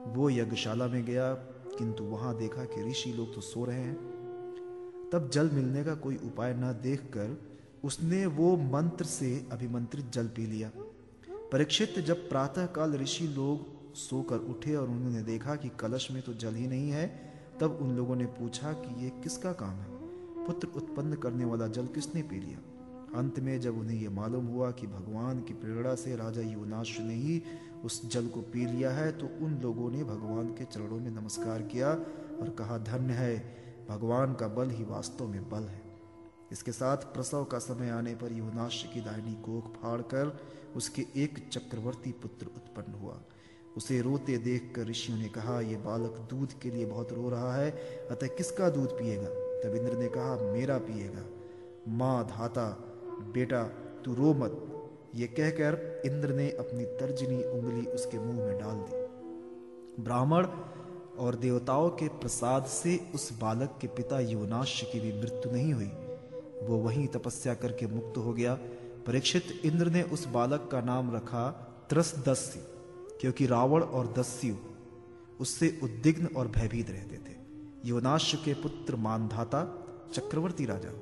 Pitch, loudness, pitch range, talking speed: 125 Hz, -34 LUFS, 115-145 Hz, 165 wpm